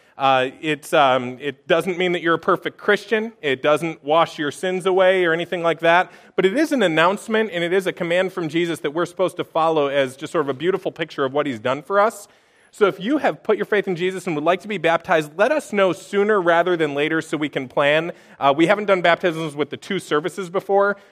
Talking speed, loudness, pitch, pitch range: 245 wpm, -20 LUFS, 175 Hz, 155-195 Hz